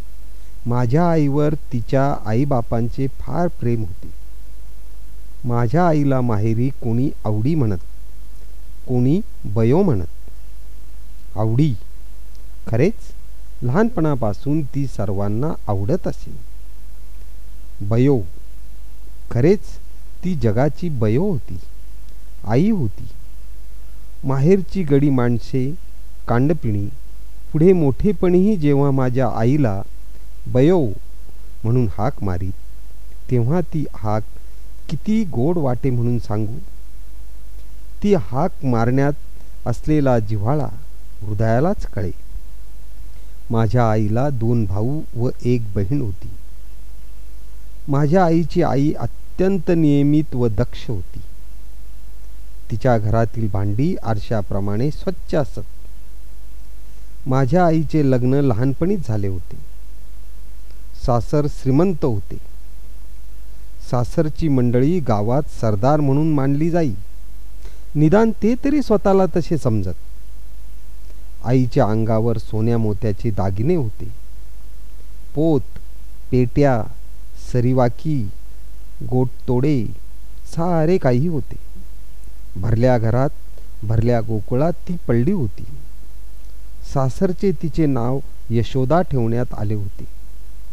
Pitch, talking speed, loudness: 115 Hz, 85 wpm, -20 LUFS